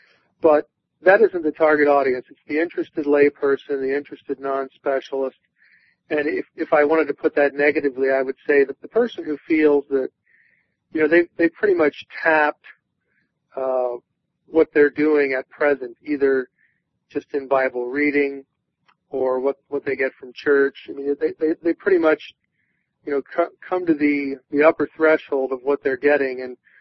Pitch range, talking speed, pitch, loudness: 135-155 Hz, 175 wpm, 145 Hz, -20 LUFS